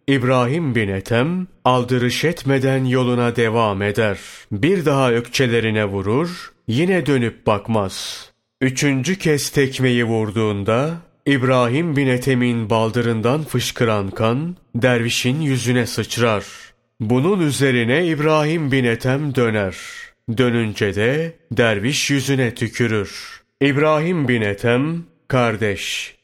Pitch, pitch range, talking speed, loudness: 125 Hz, 115-140 Hz, 100 wpm, -18 LUFS